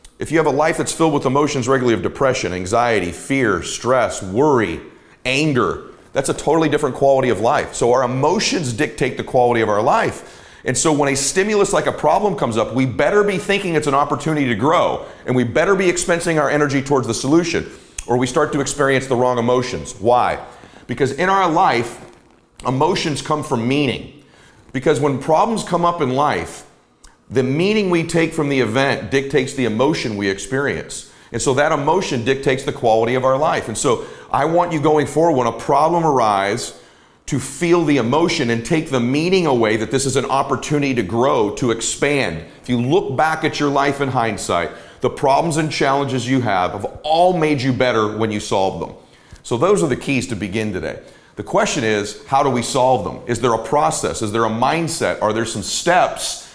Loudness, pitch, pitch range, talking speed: -18 LUFS, 140 Hz, 125-155 Hz, 200 wpm